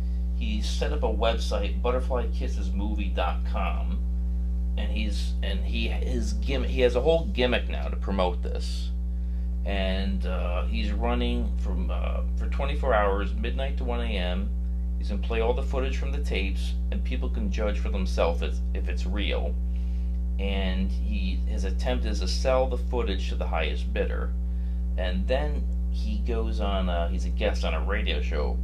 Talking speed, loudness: 165 wpm, -28 LUFS